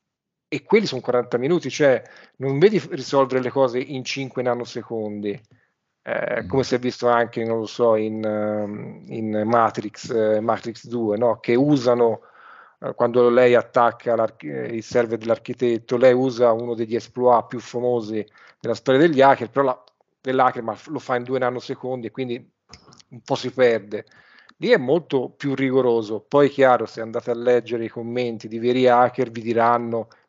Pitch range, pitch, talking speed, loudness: 115-130 Hz, 120 Hz, 160 wpm, -21 LUFS